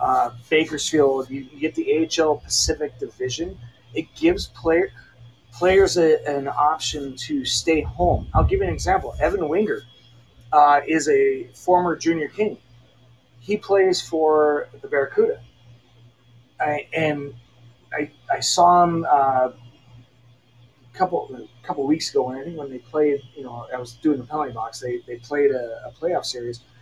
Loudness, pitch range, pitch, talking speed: -21 LUFS, 120-160 Hz, 140 Hz, 155 wpm